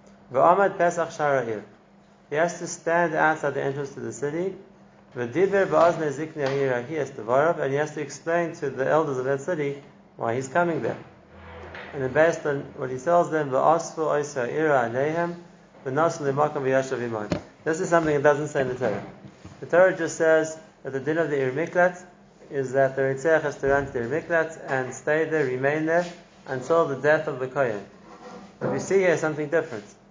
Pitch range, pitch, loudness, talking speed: 135-165 Hz, 155 Hz, -24 LUFS, 155 wpm